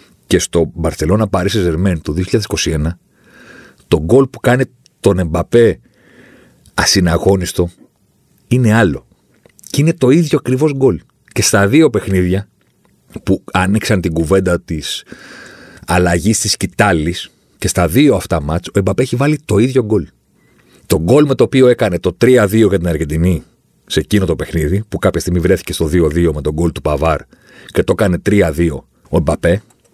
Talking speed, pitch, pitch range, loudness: 155 wpm, 95 Hz, 85-115 Hz, -14 LUFS